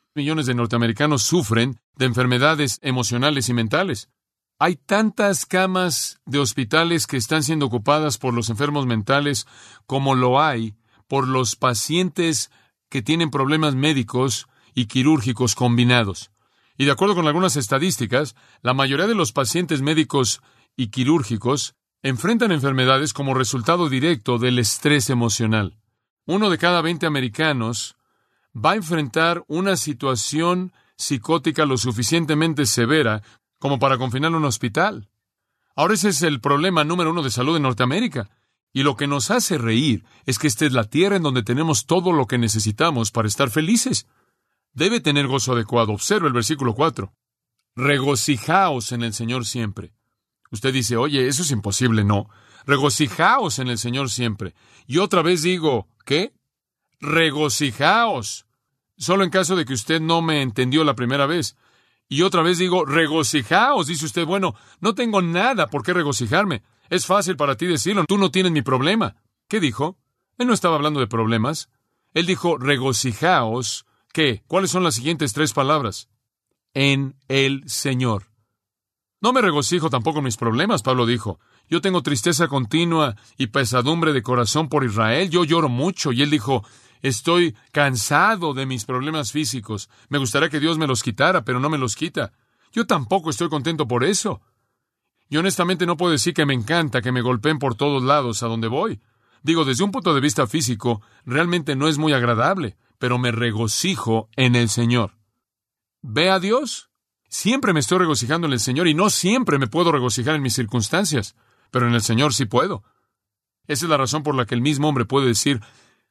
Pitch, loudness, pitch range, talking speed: 140 Hz, -20 LUFS, 120-160 Hz, 165 wpm